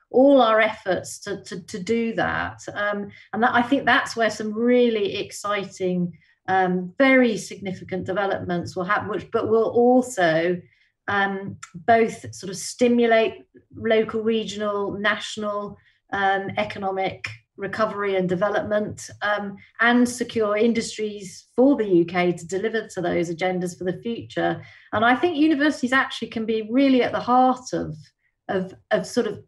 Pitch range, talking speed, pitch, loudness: 190-235 Hz, 145 wpm, 210 Hz, -22 LUFS